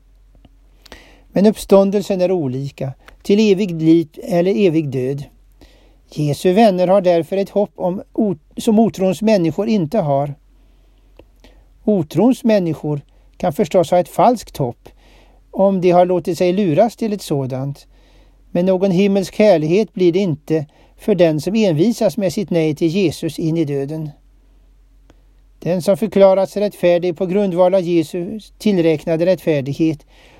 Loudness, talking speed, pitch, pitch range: -16 LUFS, 135 wpm, 180 Hz, 160-200 Hz